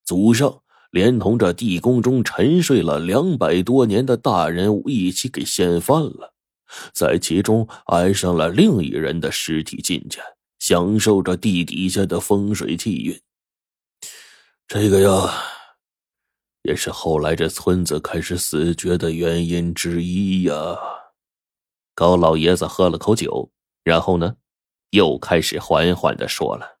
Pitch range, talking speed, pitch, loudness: 85-100 Hz, 200 characters per minute, 90 Hz, -19 LUFS